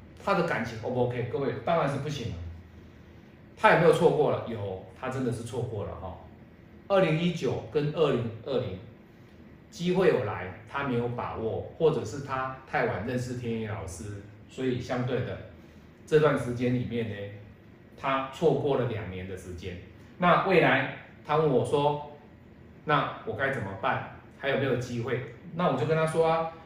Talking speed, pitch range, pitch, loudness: 250 characters per minute, 110-145 Hz, 125 Hz, -28 LUFS